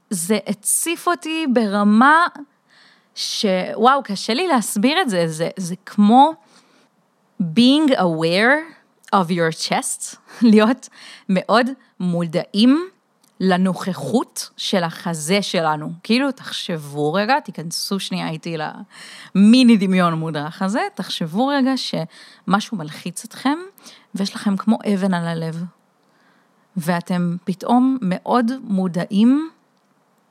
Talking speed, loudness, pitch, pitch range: 100 wpm, -19 LUFS, 210 Hz, 185-255 Hz